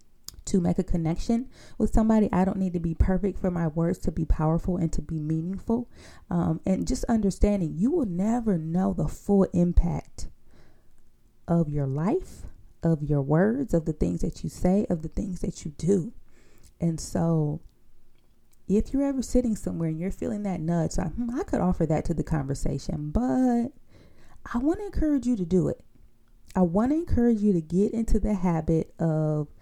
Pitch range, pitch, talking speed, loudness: 160-215 Hz, 180 Hz, 185 wpm, -27 LUFS